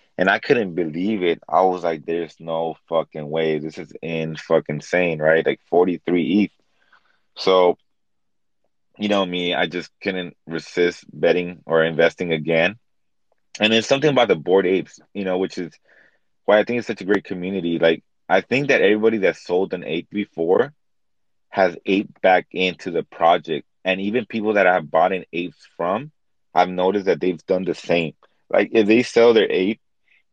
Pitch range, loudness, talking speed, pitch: 80-105 Hz, -20 LUFS, 180 wpm, 90 Hz